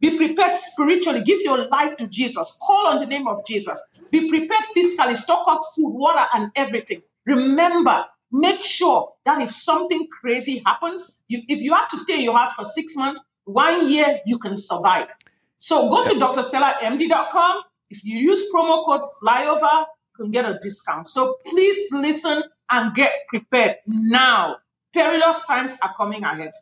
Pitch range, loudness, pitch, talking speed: 245-335 Hz, -19 LUFS, 295 Hz, 170 wpm